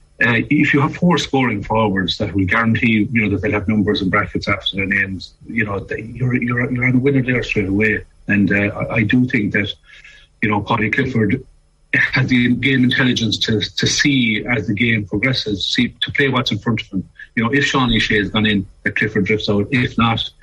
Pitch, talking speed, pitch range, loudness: 110 Hz, 225 wpm, 100-125 Hz, -17 LUFS